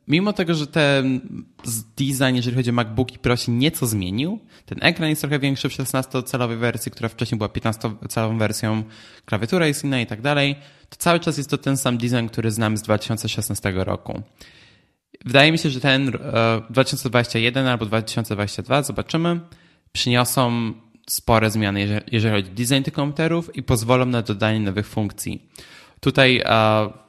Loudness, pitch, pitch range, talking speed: -21 LUFS, 125 Hz, 110-140 Hz, 155 wpm